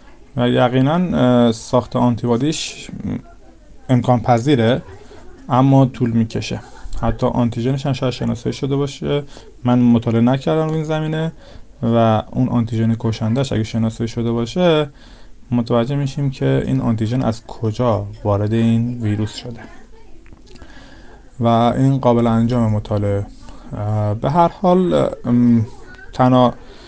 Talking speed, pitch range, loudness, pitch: 105 wpm, 115-135 Hz, -17 LUFS, 120 Hz